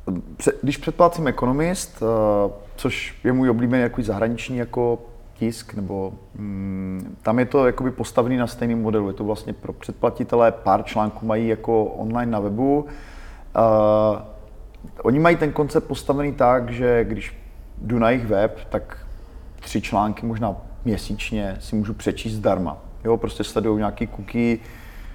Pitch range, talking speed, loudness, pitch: 100-120 Hz, 140 wpm, -22 LUFS, 110 Hz